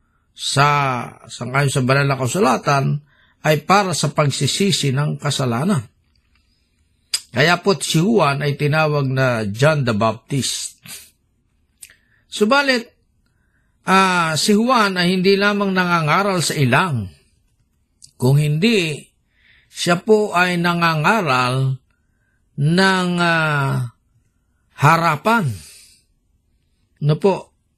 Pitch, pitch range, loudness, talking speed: 145 Hz, 115-175 Hz, -17 LUFS, 95 wpm